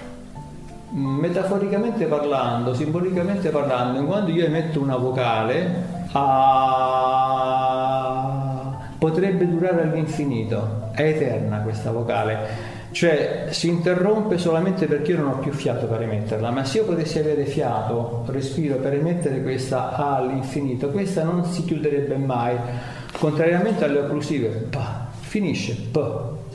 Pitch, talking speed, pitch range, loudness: 140 Hz, 115 wpm, 125-165 Hz, -22 LUFS